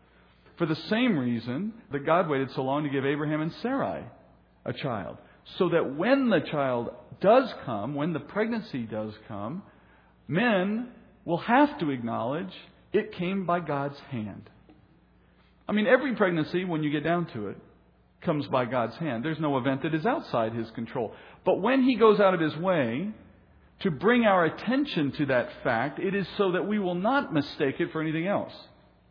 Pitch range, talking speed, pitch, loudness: 135-200 Hz, 180 wpm, 160 Hz, -27 LUFS